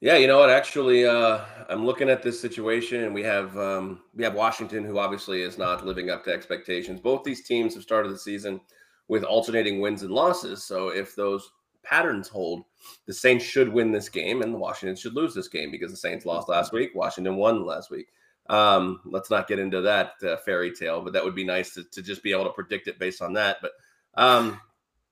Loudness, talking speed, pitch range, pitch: -25 LUFS, 220 wpm, 95-120 Hz, 105 Hz